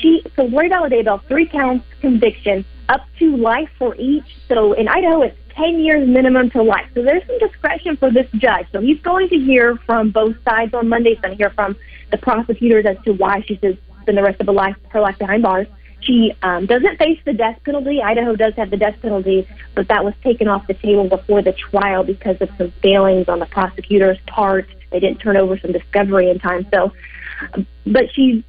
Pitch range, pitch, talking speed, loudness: 195-255 Hz, 220 Hz, 220 wpm, -16 LUFS